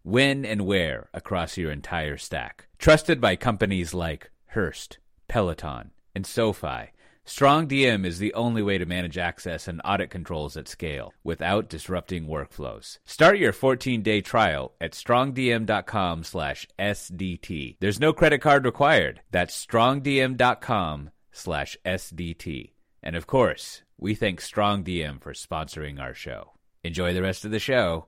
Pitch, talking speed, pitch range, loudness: 95 Hz, 130 wpm, 85-115 Hz, -25 LUFS